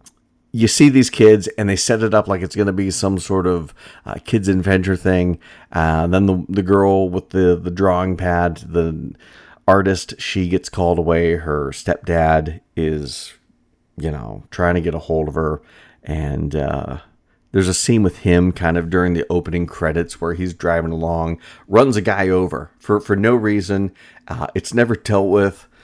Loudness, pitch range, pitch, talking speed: -17 LUFS, 85-100 Hz, 90 Hz, 185 wpm